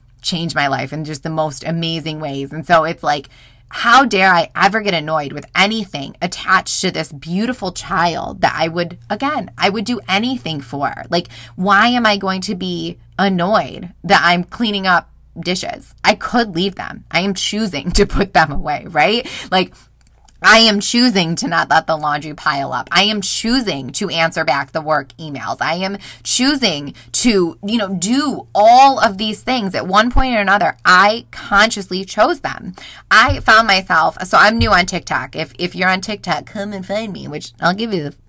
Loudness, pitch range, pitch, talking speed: -15 LUFS, 160-210 Hz, 185 Hz, 190 wpm